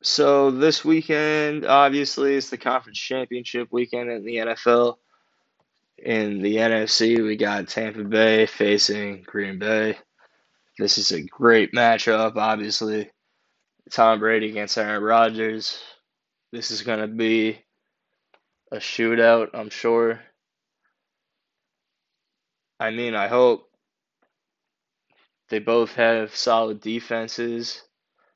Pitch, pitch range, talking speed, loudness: 115 Hz, 110-120 Hz, 110 wpm, -21 LUFS